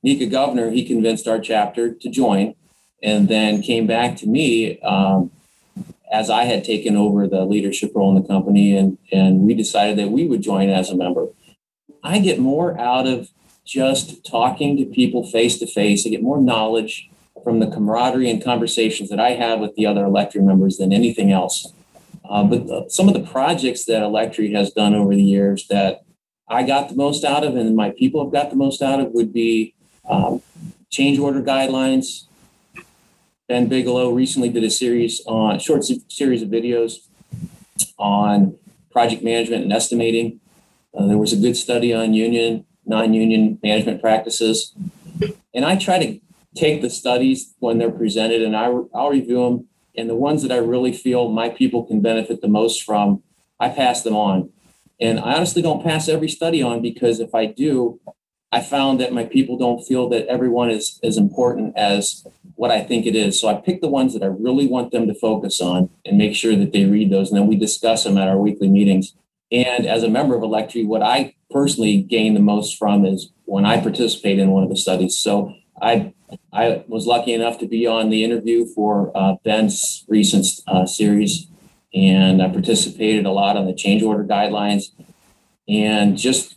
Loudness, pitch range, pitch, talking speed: -18 LUFS, 105-130 Hz, 115 Hz, 190 wpm